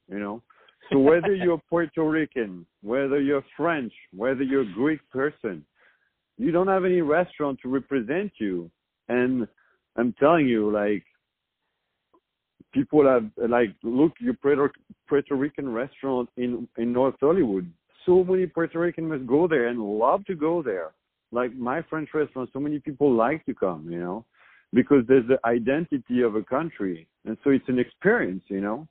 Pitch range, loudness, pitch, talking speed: 120-150 Hz, -24 LUFS, 135 Hz, 165 wpm